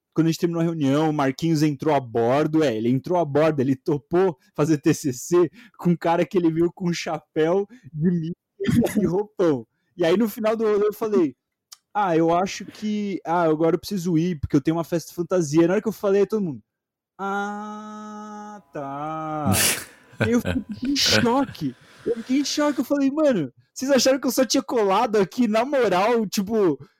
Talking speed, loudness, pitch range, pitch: 200 wpm, -22 LUFS, 155-215 Hz, 175 Hz